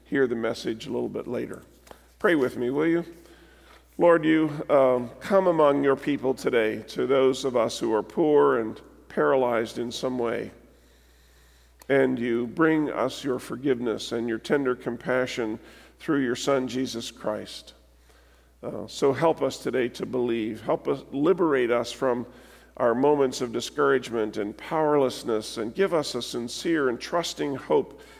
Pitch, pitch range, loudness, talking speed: 125 Hz, 115-140 Hz, -25 LUFS, 155 wpm